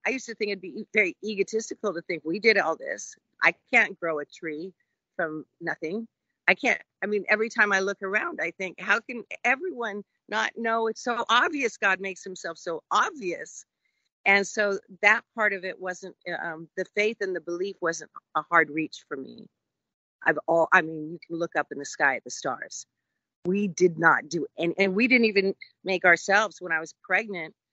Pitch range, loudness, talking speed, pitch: 170-215 Hz, -26 LUFS, 205 wpm, 195 Hz